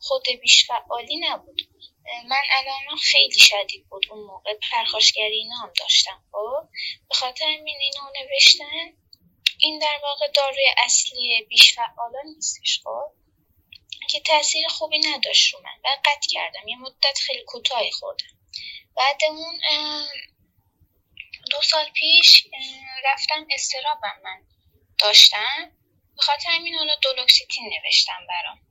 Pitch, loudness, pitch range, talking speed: 285 Hz, -17 LUFS, 250-310 Hz, 115 wpm